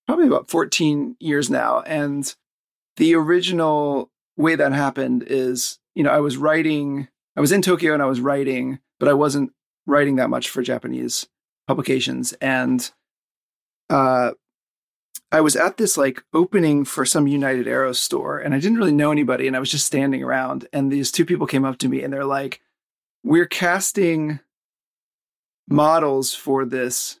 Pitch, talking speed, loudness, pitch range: 140 Hz, 165 wpm, -20 LUFS, 135-155 Hz